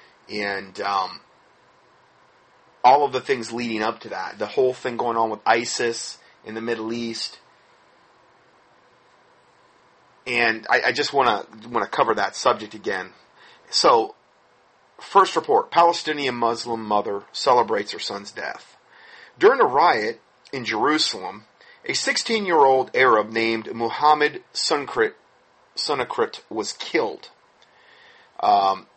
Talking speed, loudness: 115 wpm, -21 LUFS